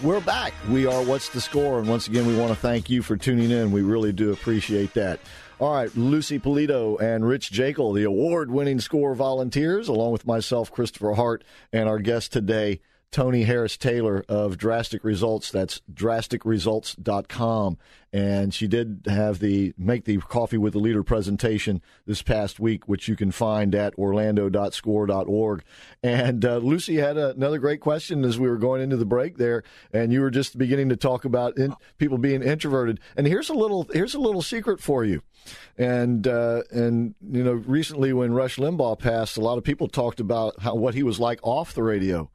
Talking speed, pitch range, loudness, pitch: 190 wpm, 105-130 Hz, -24 LUFS, 115 Hz